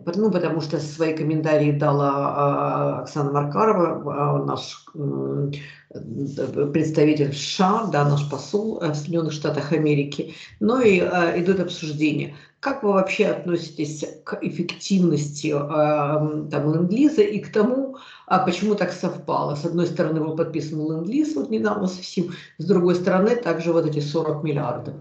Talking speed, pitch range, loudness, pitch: 130 wpm, 150-185 Hz, -22 LUFS, 160 Hz